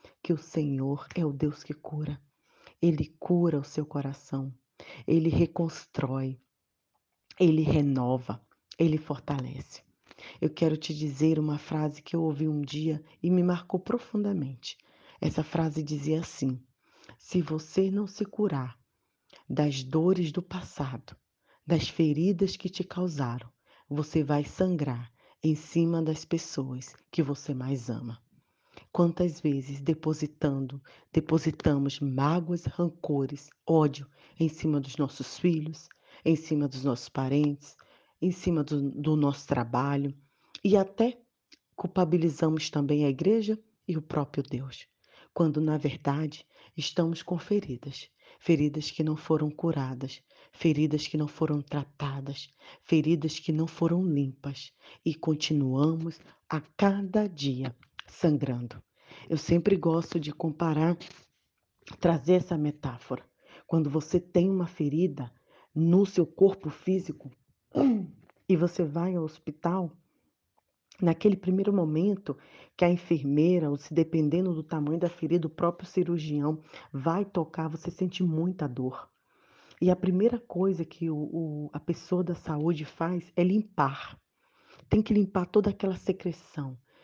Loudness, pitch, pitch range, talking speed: -29 LUFS, 155 Hz, 145-175 Hz, 130 wpm